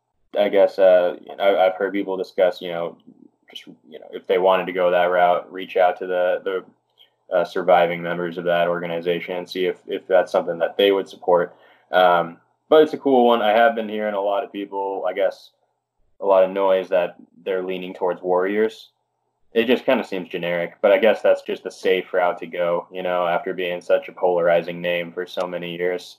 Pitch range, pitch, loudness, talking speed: 85-95 Hz, 90 Hz, -20 LUFS, 220 wpm